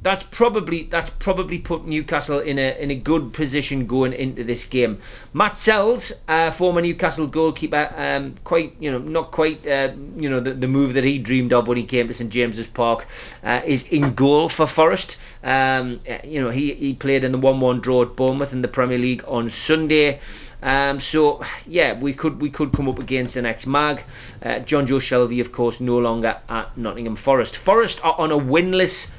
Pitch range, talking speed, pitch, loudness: 125-155 Hz, 205 wpm, 135 Hz, -20 LUFS